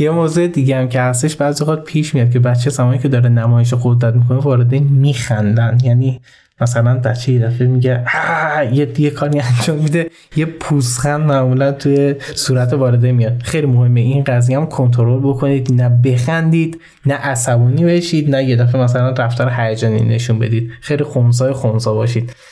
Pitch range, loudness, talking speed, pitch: 120-145 Hz, -14 LUFS, 170 wpm, 130 Hz